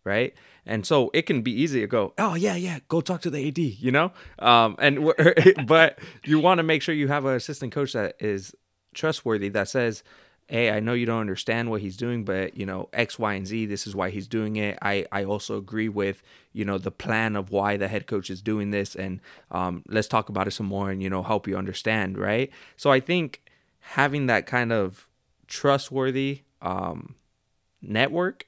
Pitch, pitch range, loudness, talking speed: 110 Hz, 100-140 Hz, -25 LUFS, 215 wpm